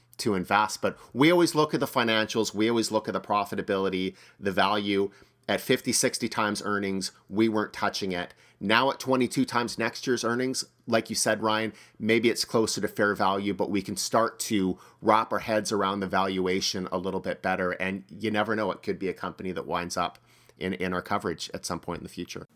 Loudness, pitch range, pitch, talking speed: -27 LUFS, 95-115 Hz, 105 Hz, 215 wpm